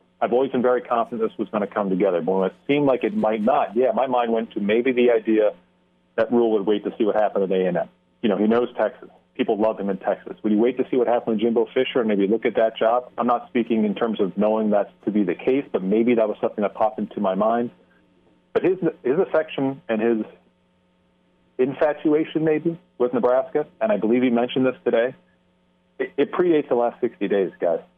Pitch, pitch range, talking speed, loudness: 115 Hz, 105-130 Hz, 235 wpm, -22 LUFS